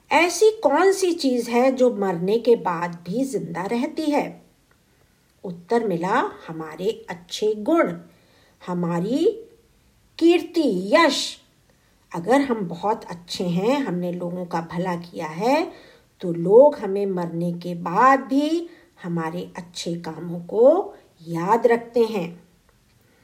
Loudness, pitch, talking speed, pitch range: -22 LUFS, 215 Hz, 120 wpm, 175-285 Hz